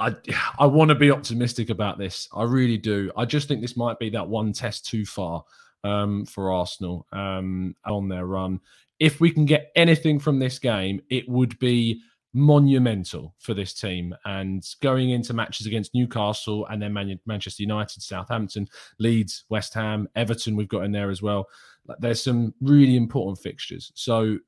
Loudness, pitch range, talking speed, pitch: -24 LUFS, 100-125 Hz, 175 wpm, 110 Hz